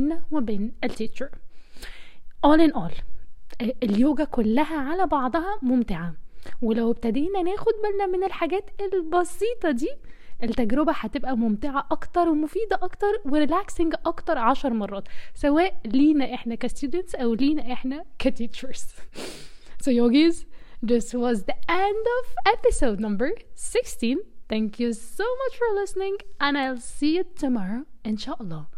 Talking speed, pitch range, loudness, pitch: 125 wpm, 240-360 Hz, -25 LUFS, 290 Hz